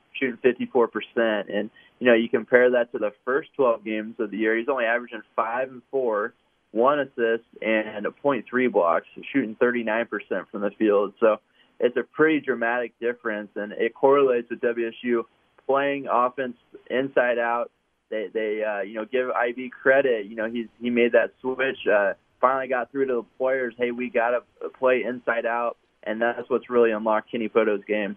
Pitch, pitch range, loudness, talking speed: 120 Hz, 110-125 Hz, -24 LUFS, 185 wpm